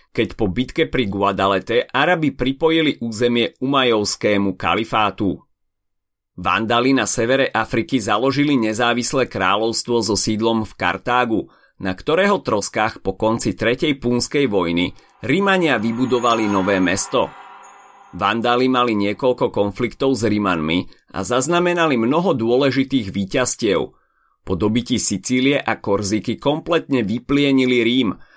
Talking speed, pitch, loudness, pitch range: 110 wpm, 115 Hz, -18 LUFS, 100-130 Hz